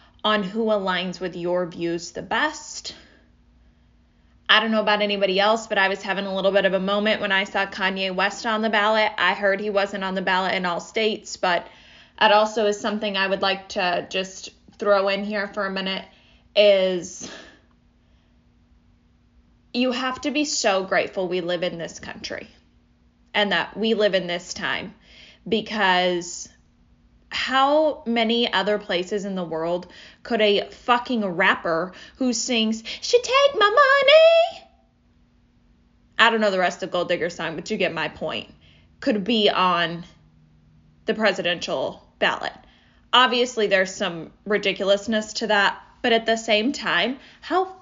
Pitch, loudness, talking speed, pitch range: 195 Hz, -21 LUFS, 160 wpm, 180-220 Hz